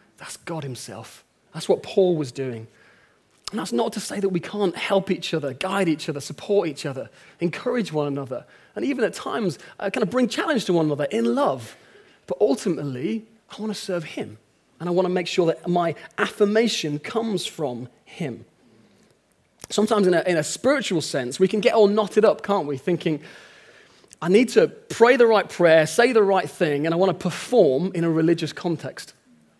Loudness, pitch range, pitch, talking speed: -22 LUFS, 150-210 Hz, 175 Hz, 195 wpm